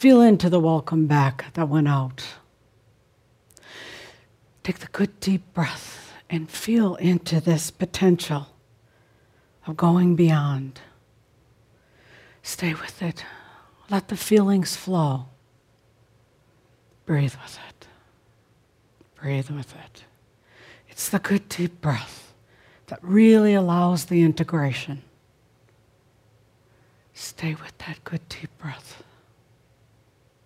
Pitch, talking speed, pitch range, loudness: 145 Hz, 100 wpm, 125-170 Hz, -22 LUFS